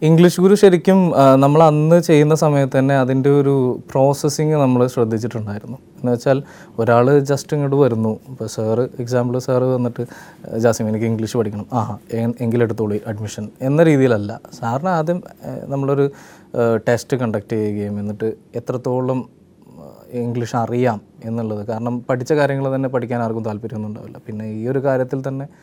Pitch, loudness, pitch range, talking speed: 125 Hz, -17 LUFS, 115-140 Hz, 130 wpm